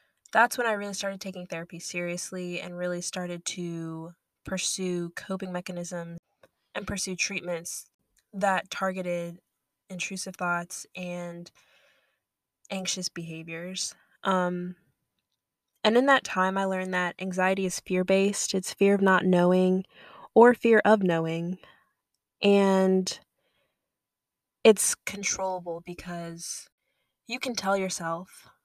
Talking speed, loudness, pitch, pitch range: 115 wpm, -27 LUFS, 185 Hz, 175-190 Hz